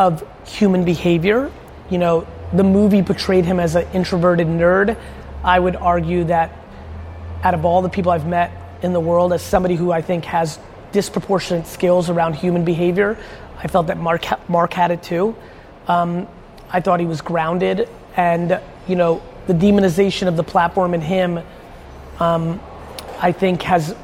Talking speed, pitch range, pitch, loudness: 165 wpm, 170-185 Hz, 175 Hz, -18 LUFS